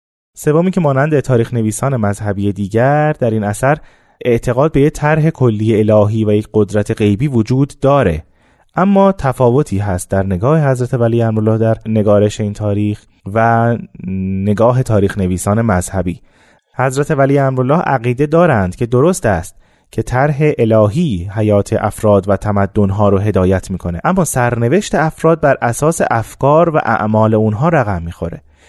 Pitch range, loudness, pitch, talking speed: 105-140 Hz, -14 LUFS, 115 Hz, 145 wpm